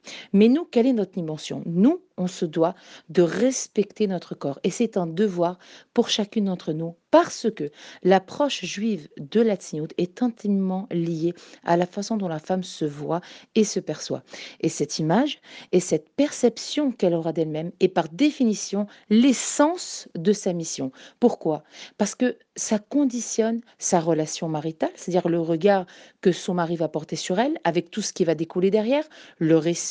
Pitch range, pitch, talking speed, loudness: 170-230 Hz, 190 Hz, 175 wpm, -24 LUFS